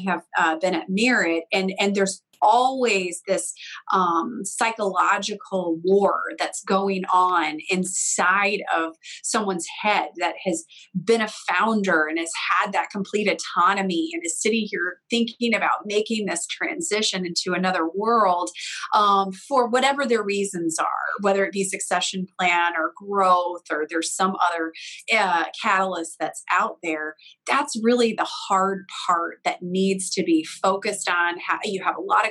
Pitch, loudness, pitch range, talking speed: 190 Hz, -22 LUFS, 175-210 Hz, 150 wpm